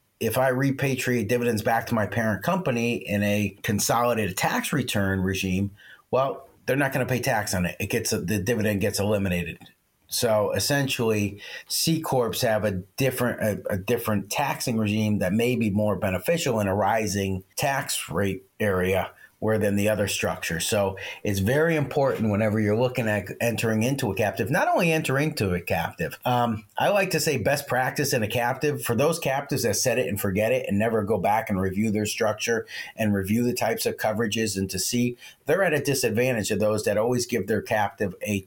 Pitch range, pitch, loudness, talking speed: 100-125 Hz, 110 Hz, -25 LUFS, 195 wpm